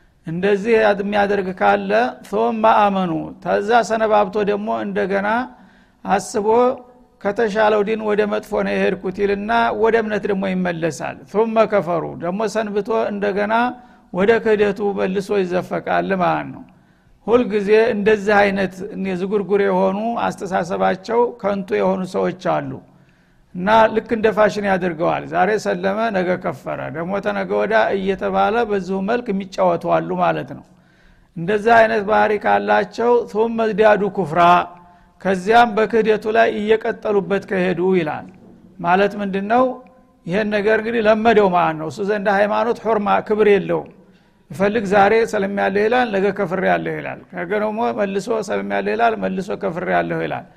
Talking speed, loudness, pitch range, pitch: 125 wpm, -18 LUFS, 195-220 Hz, 205 Hz